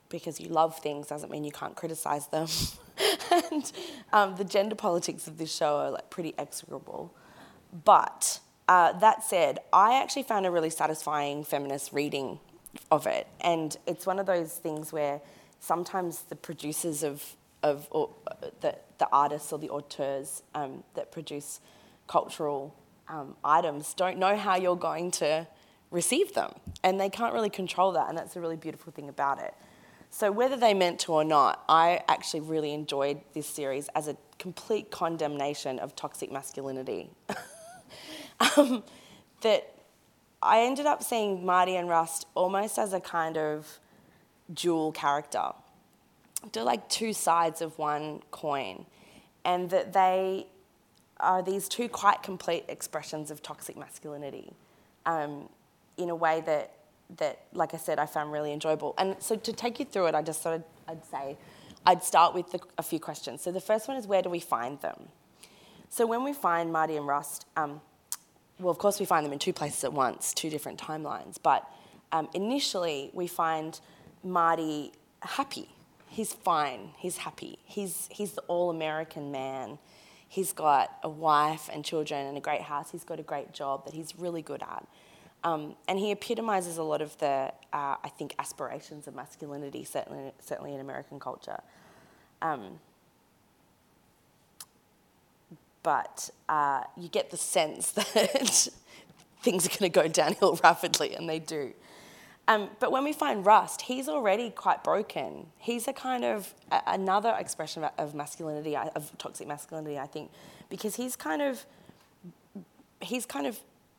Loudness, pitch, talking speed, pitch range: -29 LUFS, 165 Hz, 160 wpm, 150-195 Hz